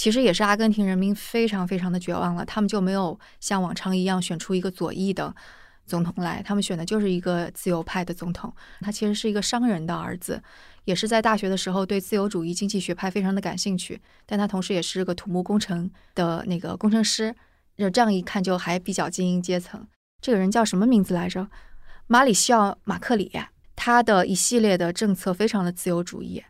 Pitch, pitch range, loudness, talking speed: 190 Hz, 180-210 Hz, -24 LUFS, 330 characters per minute